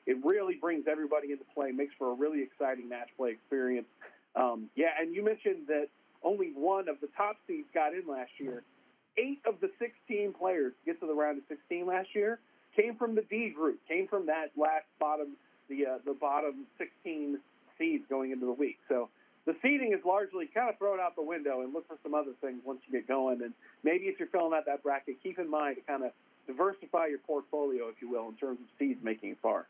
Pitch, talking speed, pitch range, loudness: 155 Hz, 225 wpm, 140-220 Hz, -34 LUFS